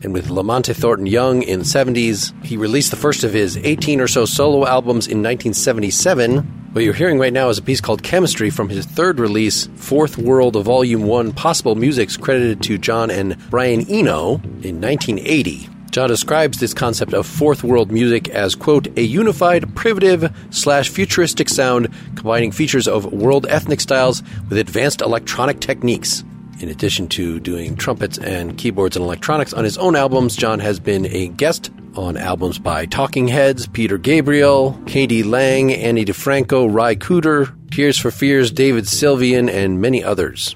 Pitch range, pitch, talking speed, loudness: 110-140 Hz, 125 Hz, 165 wpm, -16 LUFS